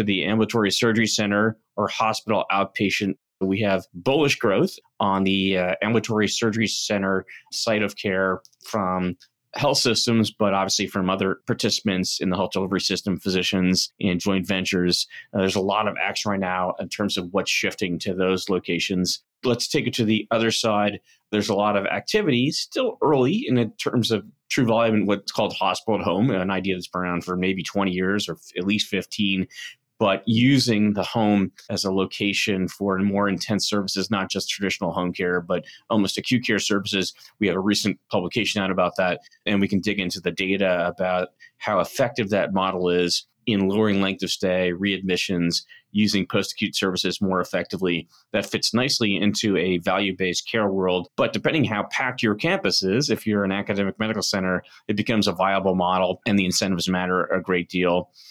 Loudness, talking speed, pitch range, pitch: -23 LUFS, 185 wpm, 95-105 Hz, 95 Hz